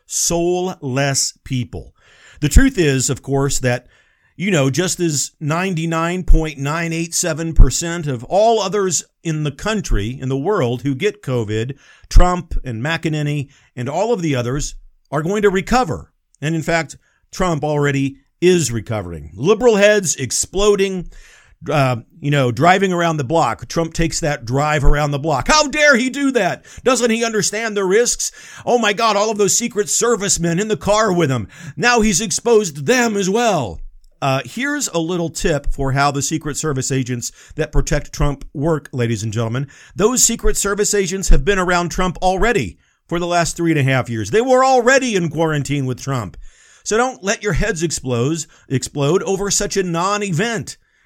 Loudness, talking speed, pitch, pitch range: -17 LUFS, 170 wpm, 165 Hz, 140-200 Hz